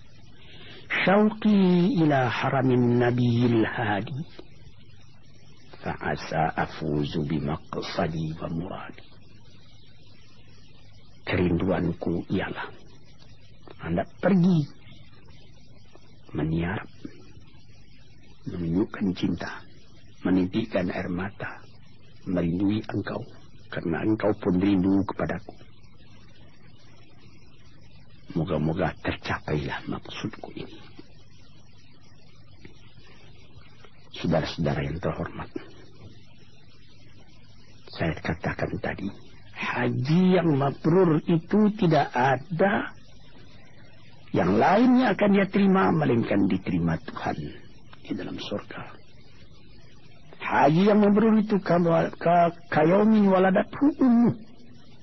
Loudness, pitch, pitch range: -25 LUFS, 125 Hz, 110-150 Hz